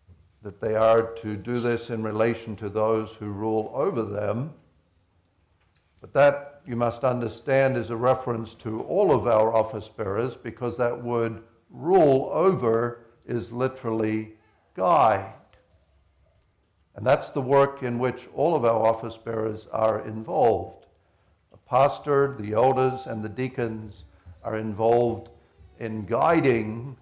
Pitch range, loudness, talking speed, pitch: 110-120 Hz, -25 LUFS, 135 wpm, 115 Hz